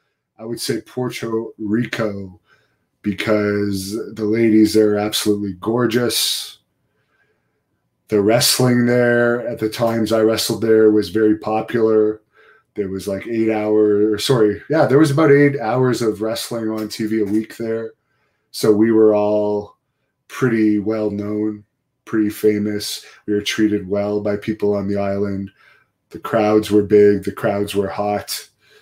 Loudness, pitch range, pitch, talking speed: -18 LUFS, 105-115 Hz, 110 Hz, 145 wpm